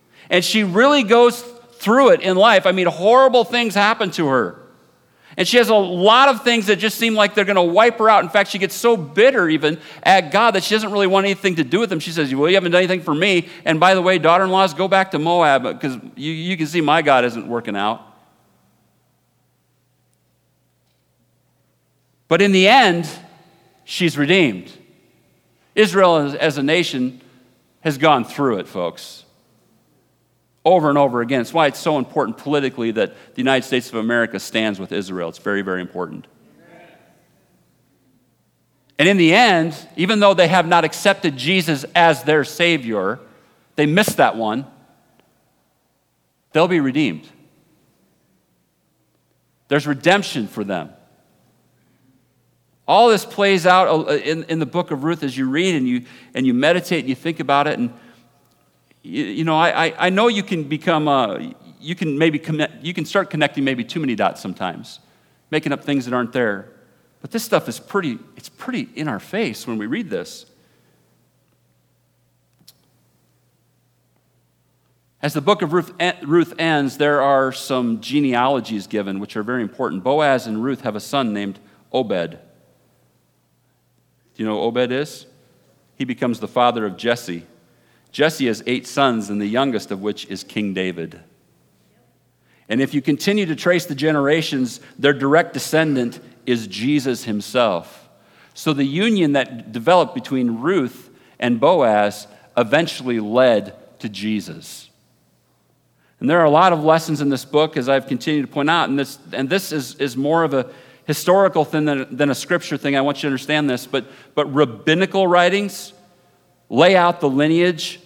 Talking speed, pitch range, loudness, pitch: 170 wpm, 125-180 Hz, -17 LUFS, 155 Hz